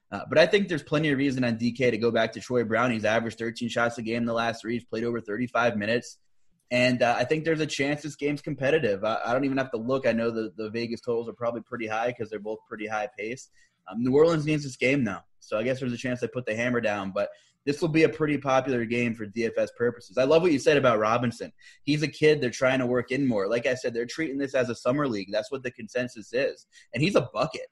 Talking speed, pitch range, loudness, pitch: 275 wpm, 115-140 Hz, -26 LUFS, 120 Hz